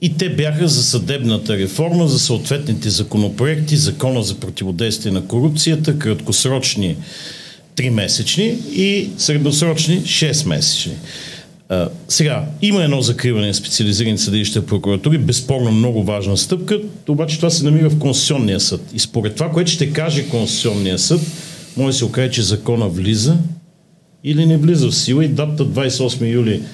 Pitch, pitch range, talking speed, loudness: 140 Hz, 115-160 Hz, 140 wpm, -16 LUFS